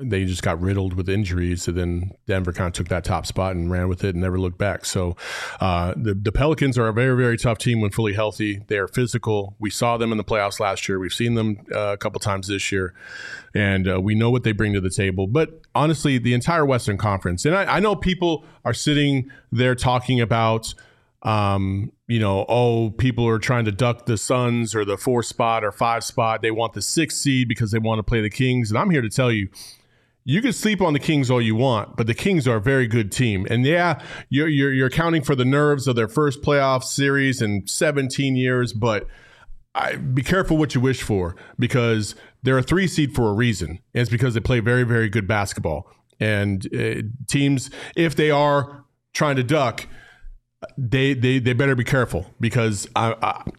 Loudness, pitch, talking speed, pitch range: -21 LUFS, 120 Hz, 220 wpm, 105-135 Hz